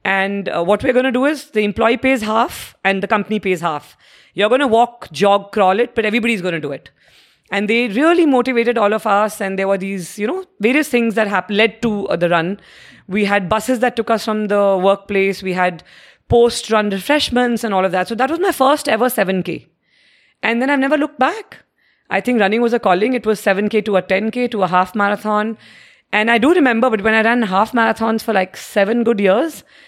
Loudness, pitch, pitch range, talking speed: -16 LUFS, 220 Hz, 195-240 Hz, 225 wpm